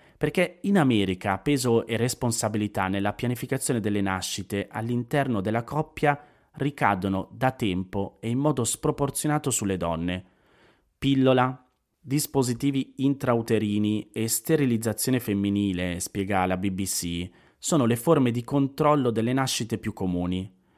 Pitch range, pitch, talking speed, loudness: 100-135 Hz, 115 Hz, 115 wpm, -26 LUFS